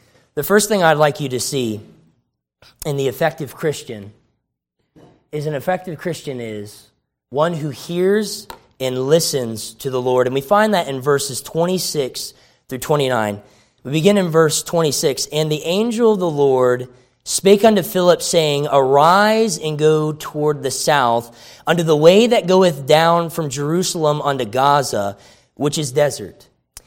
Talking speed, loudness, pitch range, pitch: 150 wpm, -17 LUFS, 125-170 Hz, 150 Hz